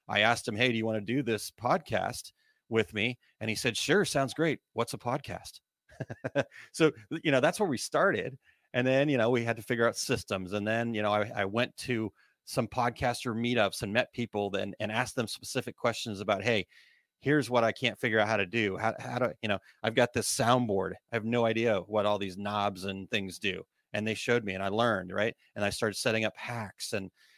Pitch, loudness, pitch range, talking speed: 115 Hz, -30 LUFS, 105-125 Hz, 230 wpm